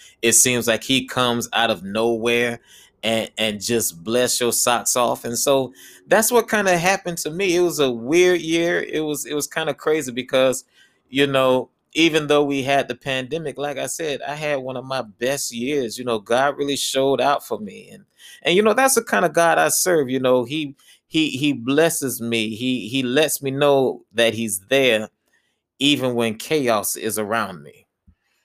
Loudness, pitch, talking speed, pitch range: -20 LUFS, 135 Hz, 200 wpm, 120-155 Hz